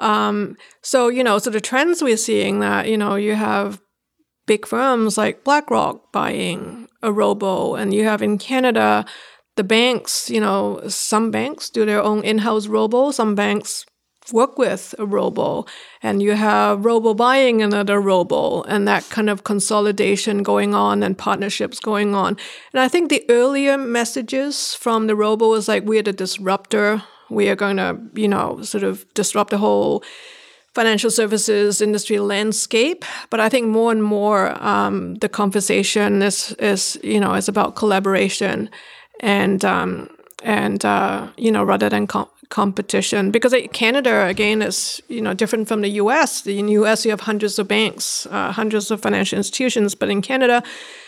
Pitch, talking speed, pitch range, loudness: 215 Hz, 165 wpm, 200-230 Hz, -18 LUFS